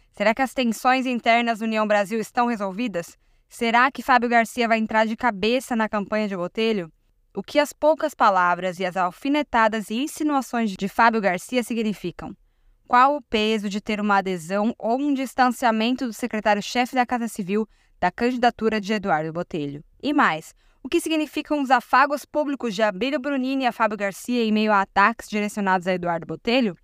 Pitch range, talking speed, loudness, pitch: 205-255 Hz, 175 wpm, -22 LUFS, 225 Hz